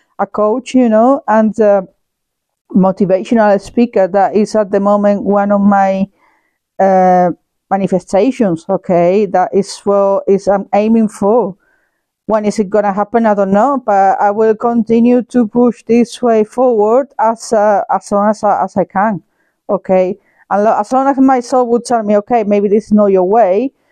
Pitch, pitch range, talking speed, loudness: 210 Hz, 195-230 Hz, 180 wpm, -12 LUFS